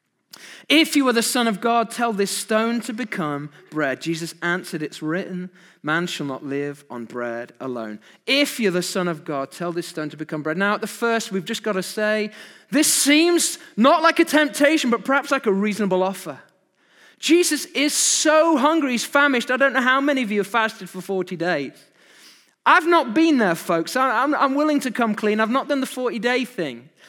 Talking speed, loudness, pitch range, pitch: 205 wpm, -20 LUFS, 175-275 Hz, 220 Hz